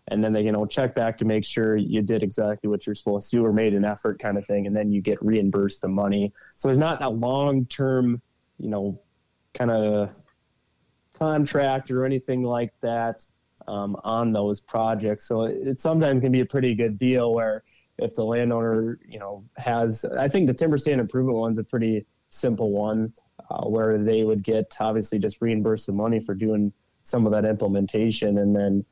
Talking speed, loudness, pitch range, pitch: 200 wpm, -24 LUFS, 105-120 Hz, 110 Hz